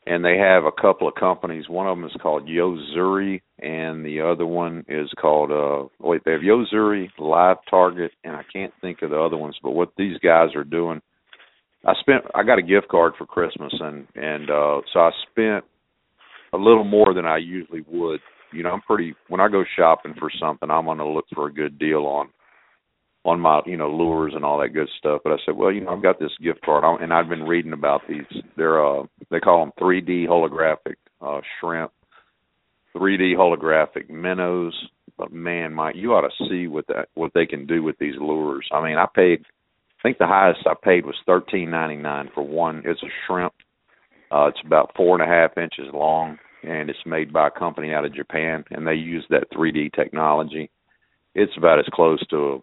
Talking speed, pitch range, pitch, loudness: 215 wpm, 75-90 Hz, 80 Hz, -21 LUFS